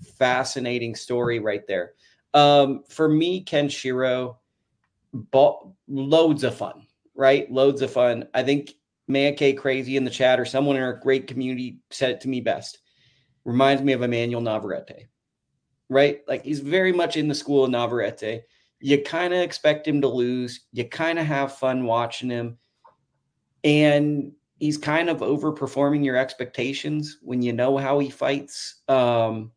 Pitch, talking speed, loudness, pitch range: 135 Hz, 160 wpm, -23 LUFS, 125-145 Hz